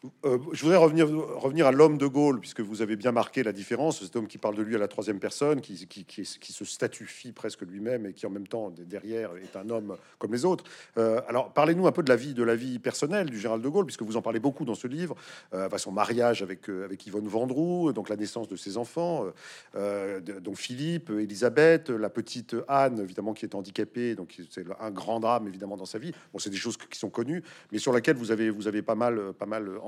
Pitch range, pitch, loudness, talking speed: 105-140 Hz, 115 Hz, -28 LUFS, 245 wpm